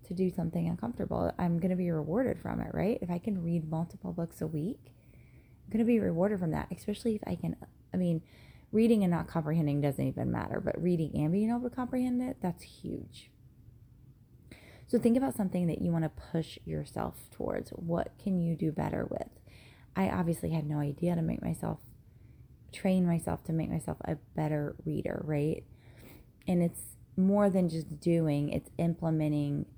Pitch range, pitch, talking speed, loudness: 145-185 Hz, 165 Hz, 185 wpm, -32 LUFS